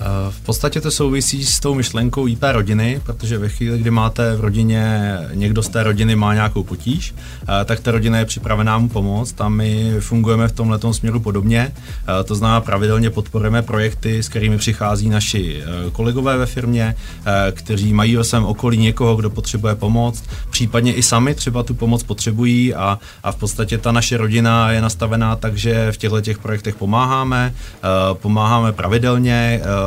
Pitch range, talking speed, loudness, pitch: 105-115 Hz, 165 wpm, -17 LUFS, 110 Hz